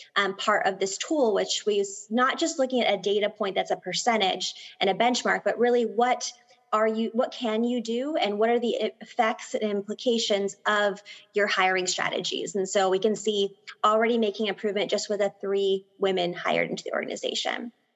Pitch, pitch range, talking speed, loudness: 210 Hz, 200-240 Hz, 190 wpm, -26 LUFS